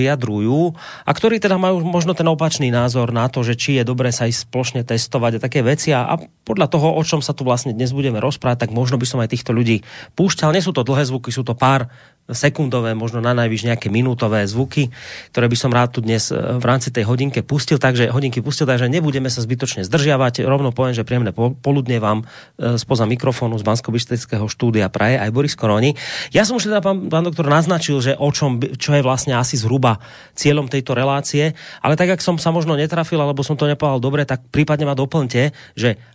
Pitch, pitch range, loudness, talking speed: 130 Hz, 120-150 Hz, -18 LUFS, 210 wpm